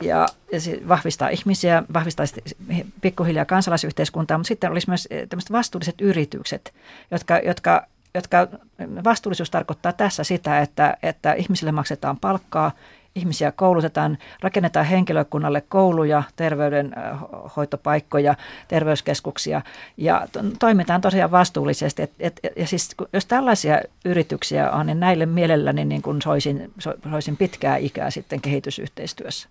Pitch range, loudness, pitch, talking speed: 150-185 Hz, -21 LUFS, 170 Hz, 115 wpm